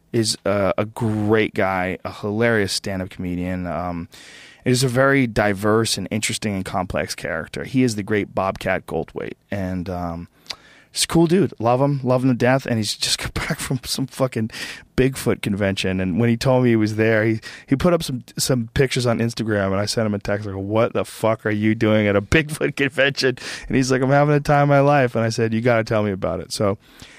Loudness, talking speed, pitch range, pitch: -20 LUFS, 225 wpm, 100-130 Hz, 115 Hz